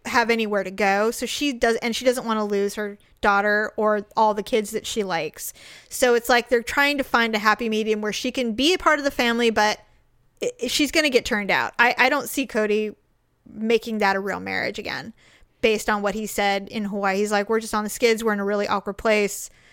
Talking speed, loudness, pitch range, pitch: 245 wpm, -22 LUFS, 210-240 Hz, 220 Hz